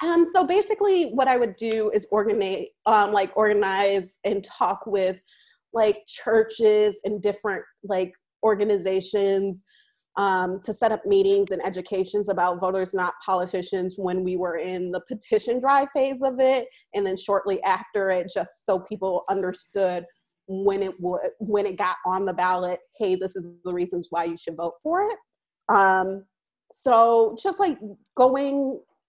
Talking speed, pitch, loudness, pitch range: 155 wpm, 200 Hz, -24 LUFS, 185-230 Hz